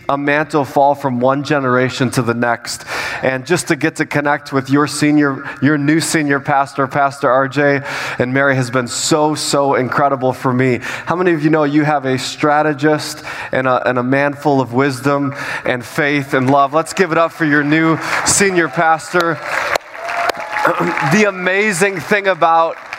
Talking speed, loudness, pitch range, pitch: 175 wpm, -15 LUFS, 135-160 Hz, 145 Hz